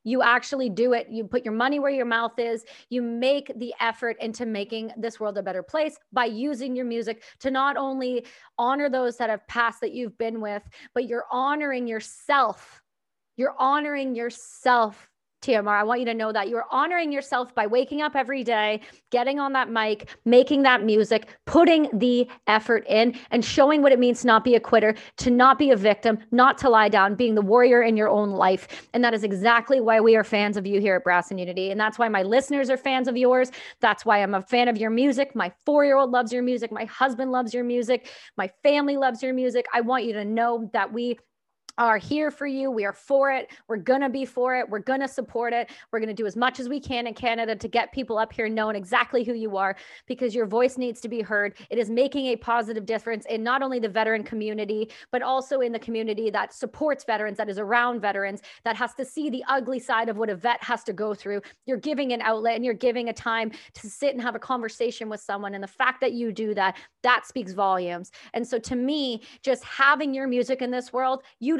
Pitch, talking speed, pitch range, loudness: 240 Hz, 235 wpm, 220-260 Hz, -24 LUFS